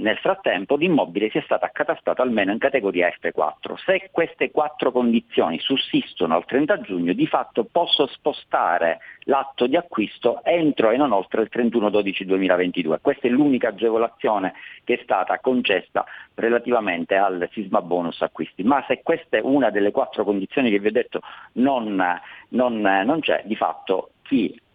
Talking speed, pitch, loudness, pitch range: 160 wpm, 115 Hz, -21 LUFS, 95-135 Hz